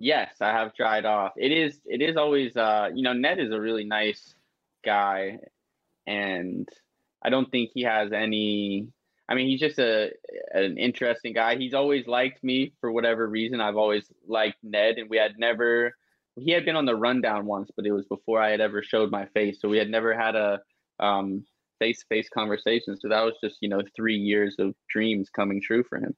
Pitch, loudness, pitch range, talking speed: 110 Hz, -26 LUFS, 105-125 Hz, 205 wpm